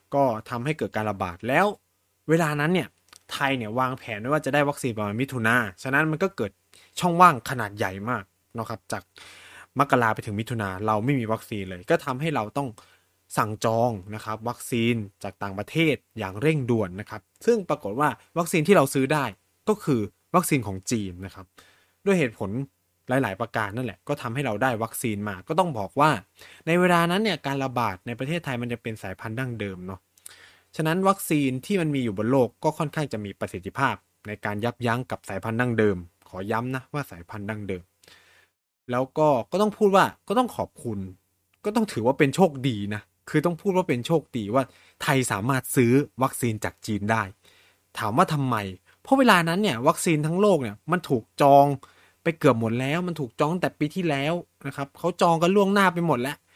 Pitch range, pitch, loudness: 105-155 Hz, 130 Hz, -25 LUFS